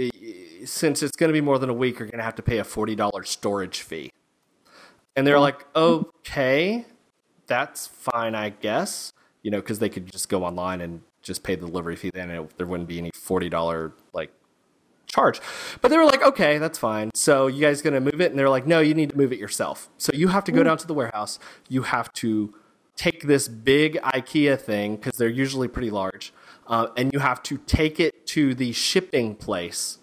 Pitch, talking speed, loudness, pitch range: 130 Hz, 220 wpm, -23 LUFS, 105-150 Hz